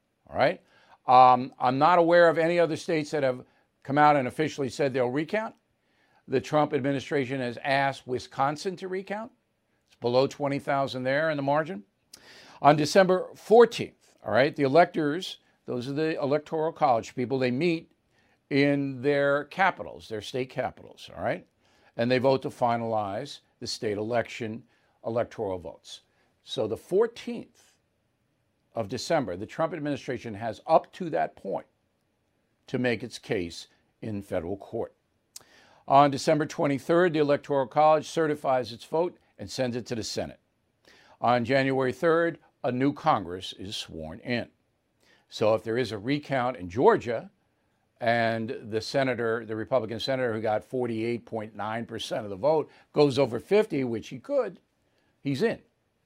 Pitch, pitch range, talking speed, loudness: 135 Hz, 115-150 Hz, 145 wpm, -27 LUFS